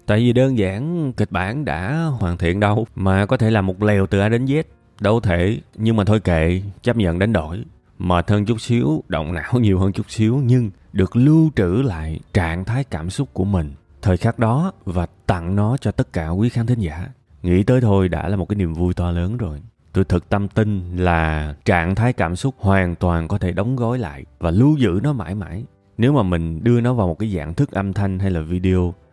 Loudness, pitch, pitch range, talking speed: -19 LUFS, 100 Hz, 90-115 Hz, 235 wpm